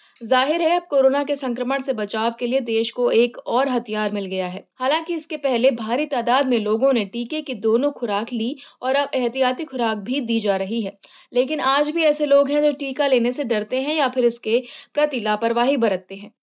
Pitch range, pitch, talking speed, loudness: 230-280 Hz, 255 Hz, 220 wpm, -21 LUFS